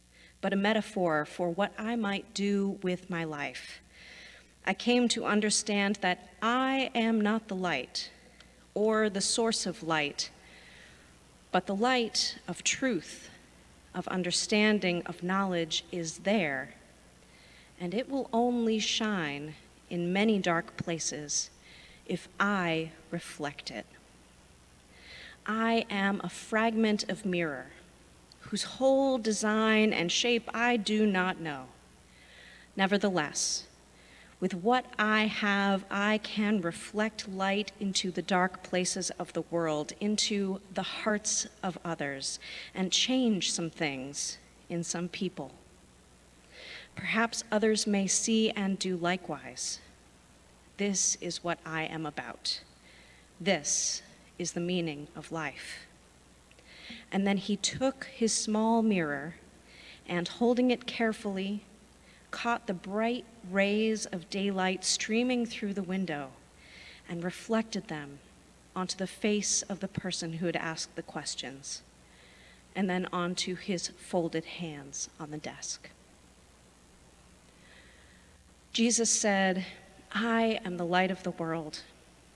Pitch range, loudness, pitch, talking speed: 165-215 Hz, -31 LUFS, 185 Hz, 120 wpm